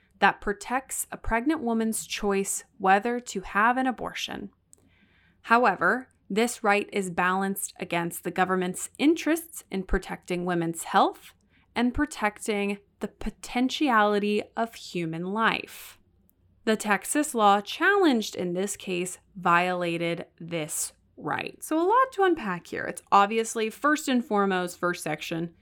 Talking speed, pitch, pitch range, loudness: 125 wpm, 205 Hz, 180-240 Hz, -26 LUFS